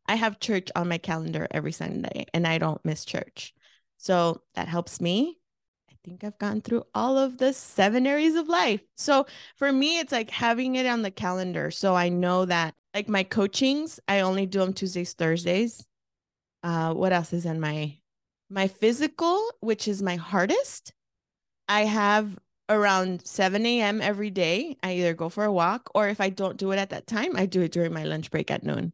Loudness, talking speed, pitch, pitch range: -26 LUFS, 195 wpm, 195 Hz, 175-230 Hz